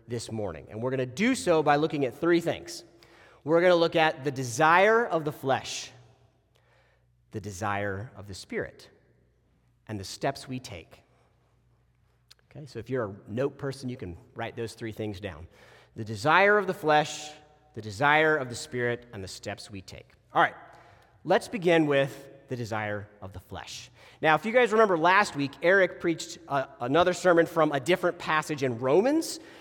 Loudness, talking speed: -26 LUFS, 180 wpm